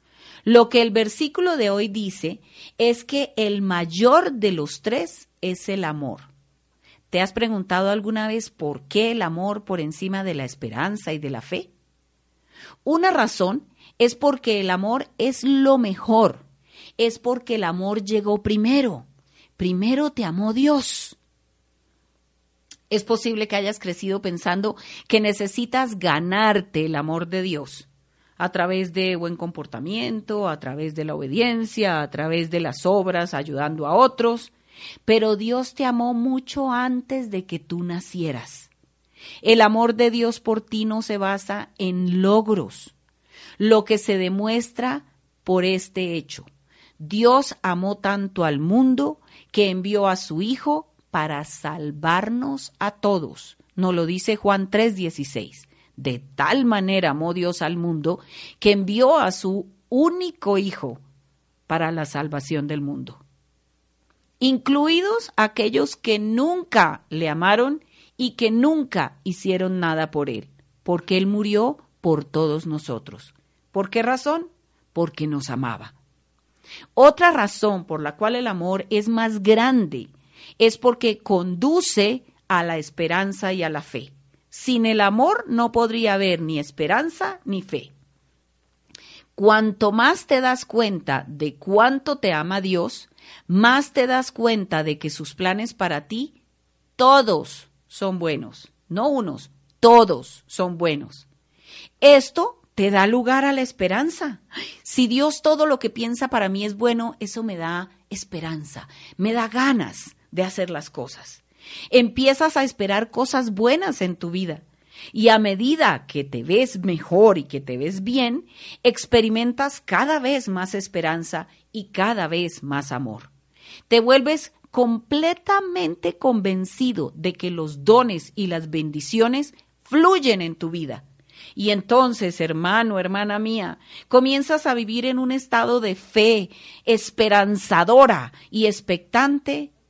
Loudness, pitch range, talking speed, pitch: -21 LUFS, 160-235 Hz, 140 wpm, 200 Hz